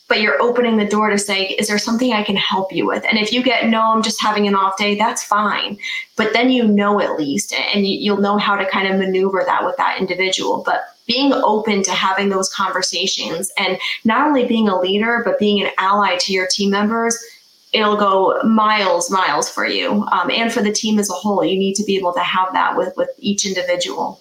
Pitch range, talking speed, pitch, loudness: 190-225 Hz, 235 wpm, 205 Hz, -16 LUFS